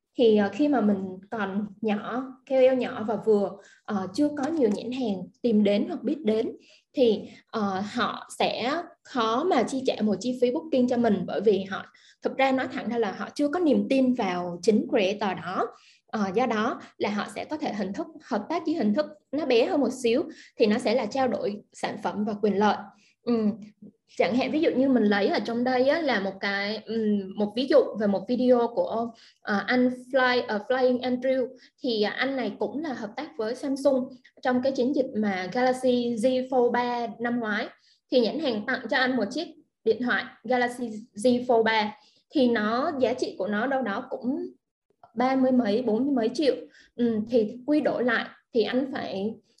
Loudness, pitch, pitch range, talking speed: -26 LUFS, 240 Hz, 215-260 Hz, 205 wpm